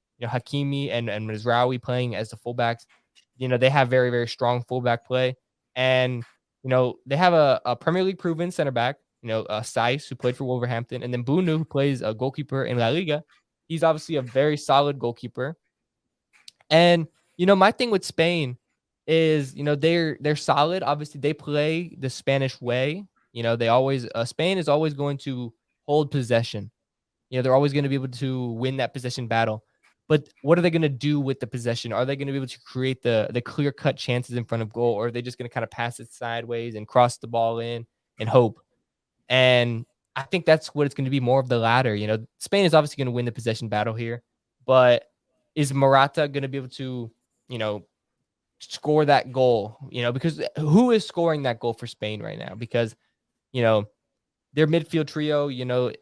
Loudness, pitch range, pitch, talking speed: -24 LUFS, 120-145 Hz, 130 Hz, 215 wpm